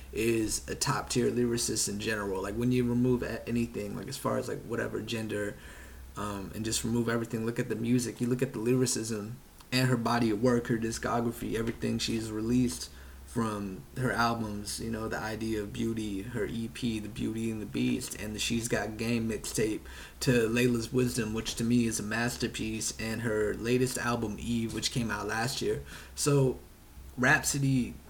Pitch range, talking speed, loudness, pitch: 110-120 Hz, 185 wpm, -31 LUFS, 115 Hz